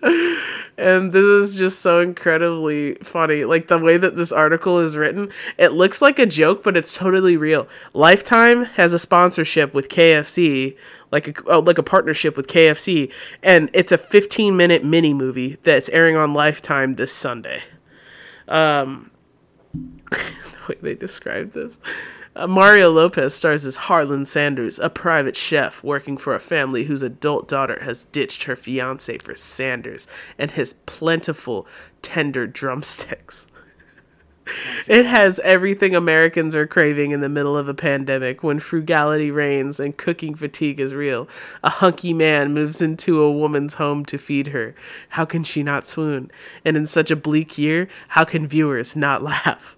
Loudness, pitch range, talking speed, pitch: -17 LUFS, 145-175 Hz, 160 wpm, 160 Hz